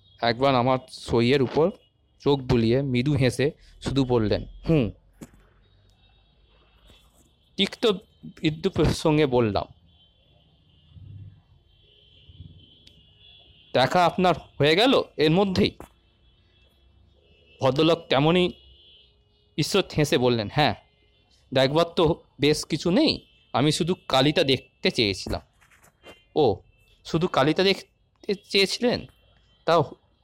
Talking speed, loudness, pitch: 85 wpm, -23 LUFS, 125 Hz